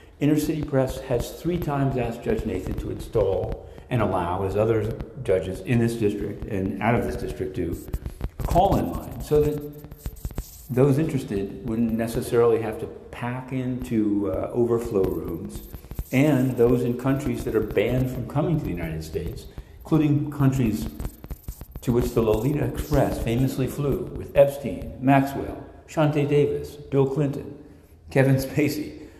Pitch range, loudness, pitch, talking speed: 105-140 Hz, -24 LUFS, 125 Hz, 150 wpm